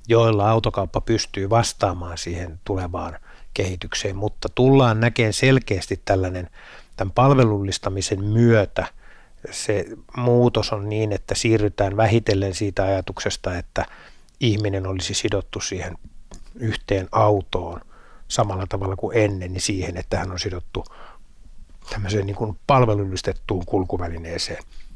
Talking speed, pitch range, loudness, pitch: 110 wpm, 95-110 Hz, -22 LUFS, 100 Hz